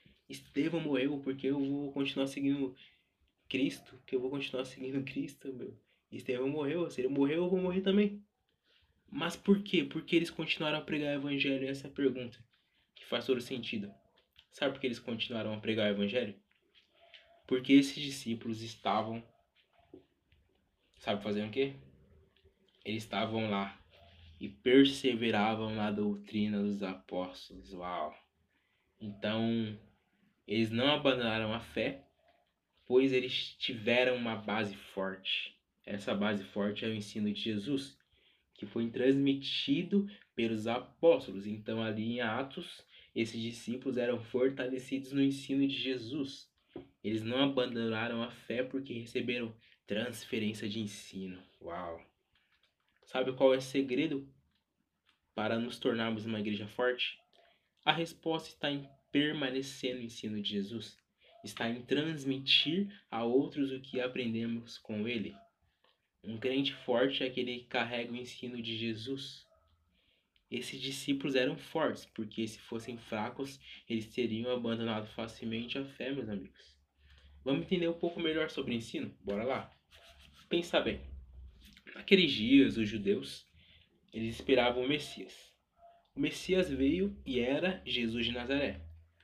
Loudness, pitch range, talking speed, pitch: -34 LUFS, 110-135 Hz, 135 wpm, 125 Hz